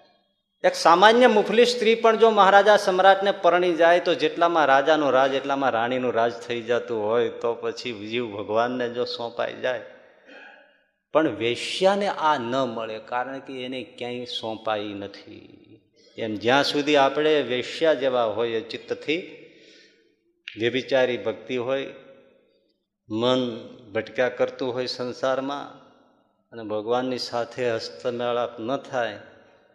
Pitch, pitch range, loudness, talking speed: 130 Hz, 120-175 Hz, -23 LUFS, 120 wpm